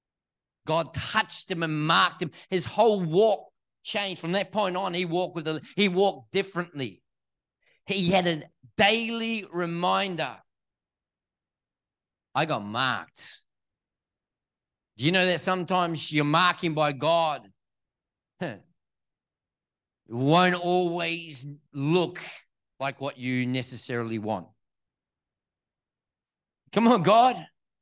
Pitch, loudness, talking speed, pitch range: 170 Hz, -26 LUFS, 110 wpm, 135-185 Hz